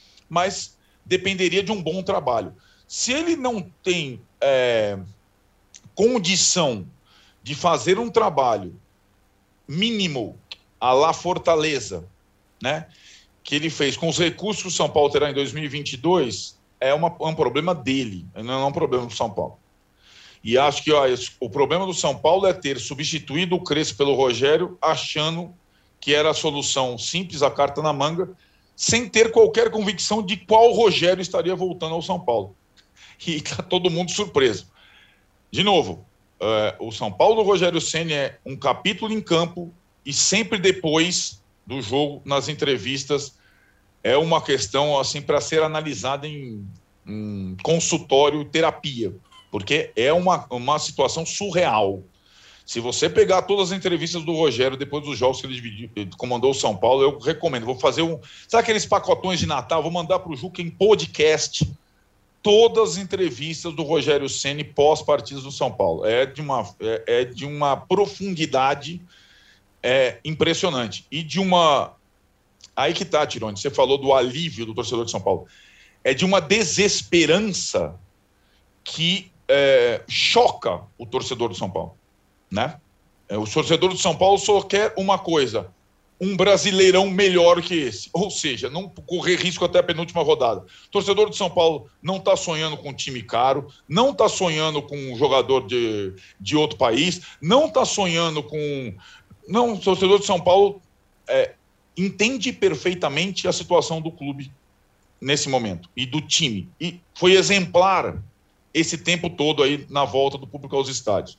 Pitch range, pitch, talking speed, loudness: 135-185 Hz, 160 Hz, 160 wpm, -21 LUFS